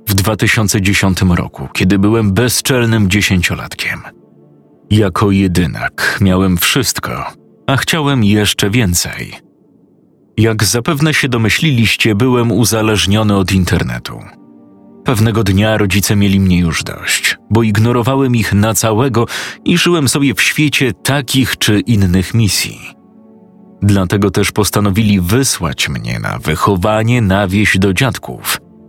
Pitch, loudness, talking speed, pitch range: 105 Hz, -12 LUFS, 115 wpm, 95-120 Hz